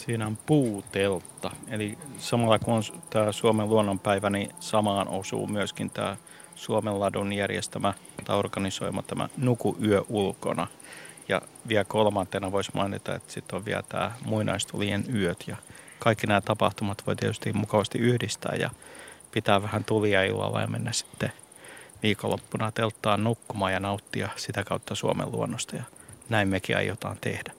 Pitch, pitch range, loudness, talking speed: 105 Hz, 100-115 Hz, -28 LUFS, 140 wpm